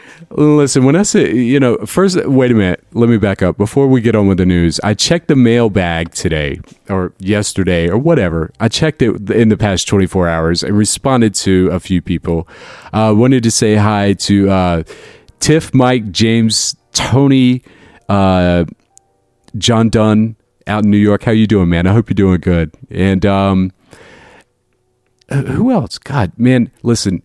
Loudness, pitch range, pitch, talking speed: -12 LUFS, 95-125 Hz, 105 Hz, 170 wpm